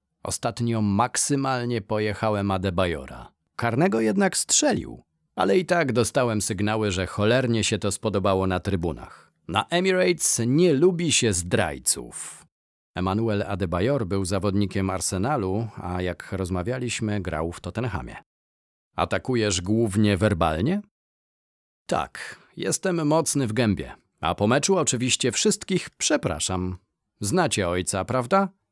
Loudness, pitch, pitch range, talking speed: -24 LUFS, 110 Hz, 95-130 Hz, 110 wpm